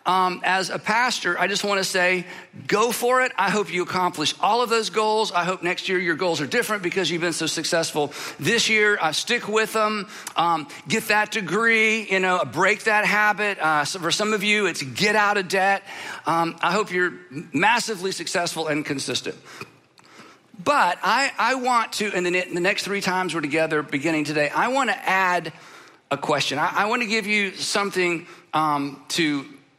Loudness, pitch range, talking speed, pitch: -22 LUFS, 170-210 Hz, 200 wpm, 185 Hz